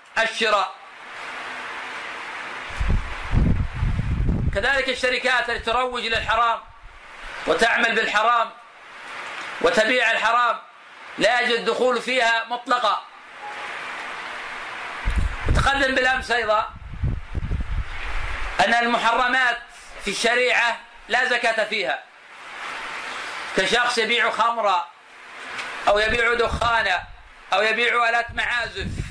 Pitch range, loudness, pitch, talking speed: 220-245 Hz, -22 LUFS, 230 Hz, 70 wpm